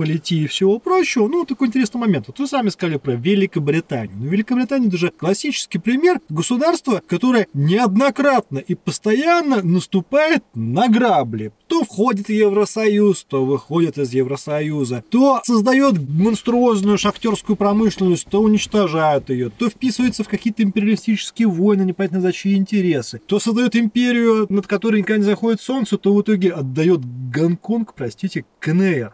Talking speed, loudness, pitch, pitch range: 145 wpm, -18 LUFS, 205 Hz, 170-230 Hz